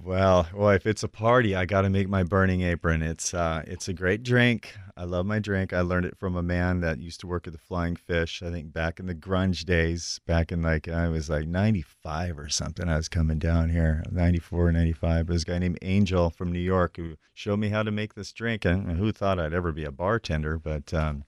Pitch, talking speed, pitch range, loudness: 90 Hz, 245 wpm, 85-95 Hz, -26 LUFS